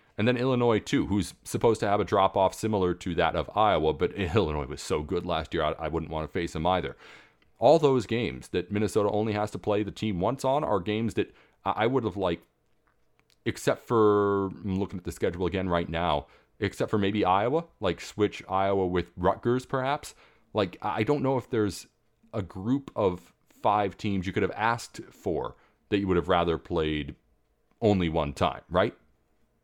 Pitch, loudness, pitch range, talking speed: 100 Hz, -28 LUFS, 90-110 Hz, 195 wpm